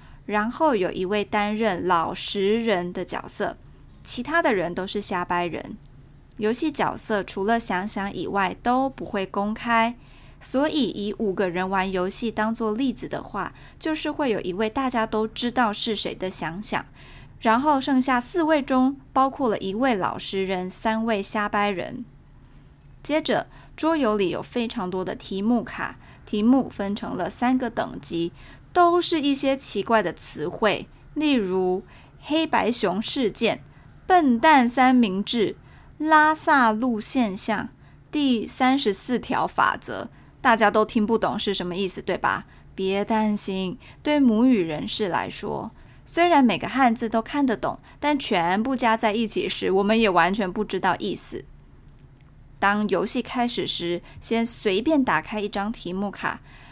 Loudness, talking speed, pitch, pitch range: -23 LUFS, 220 characters per minute, 220 Hz, 195-255 Hz